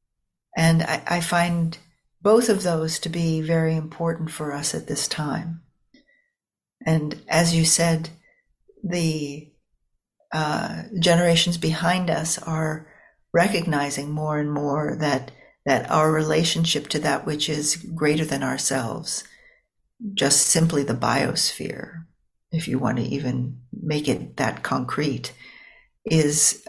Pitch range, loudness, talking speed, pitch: 150-170 Hz, -22 LUFS, 125 wpm, 160 Hz